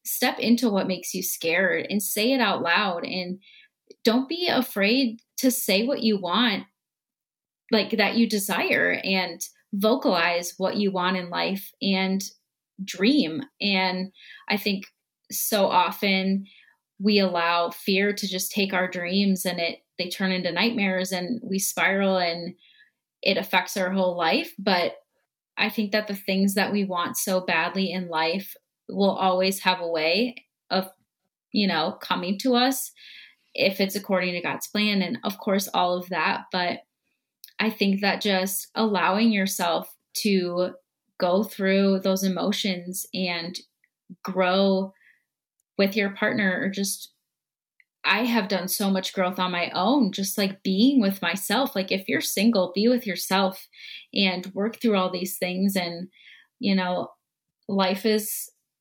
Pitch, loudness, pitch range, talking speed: 195 Hz, -24 LUFS, 185-215 Hz, 150 wpm